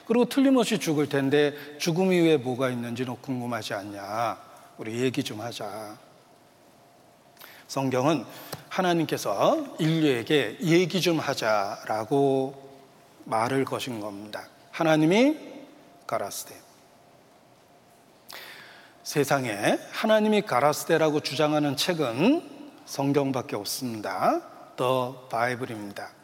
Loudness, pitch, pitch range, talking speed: -26 LUFS, 145 Hz, 130-185 Hz, 235 characters per minute